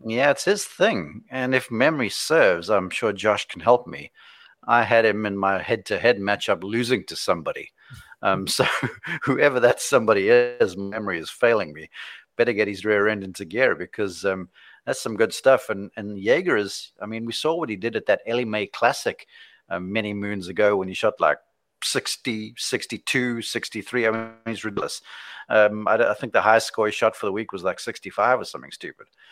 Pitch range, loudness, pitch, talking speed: 100-120 Hz, -23 LUFS, 110 Hz, 200 wpm